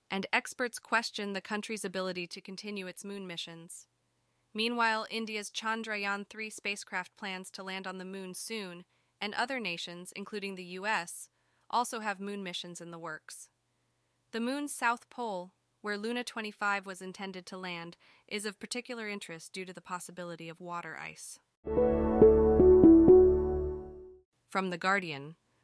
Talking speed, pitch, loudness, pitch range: 145 wpm, 200 Hz, -31 LUFS, 180-225 Hz